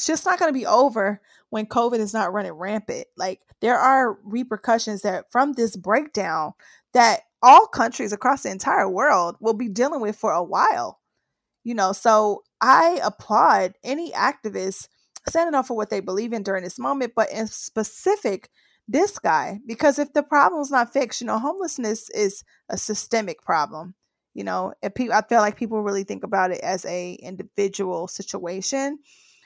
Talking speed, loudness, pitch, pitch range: 175 wpm, -22 LUFS, 220 Hz, 200-265 Hz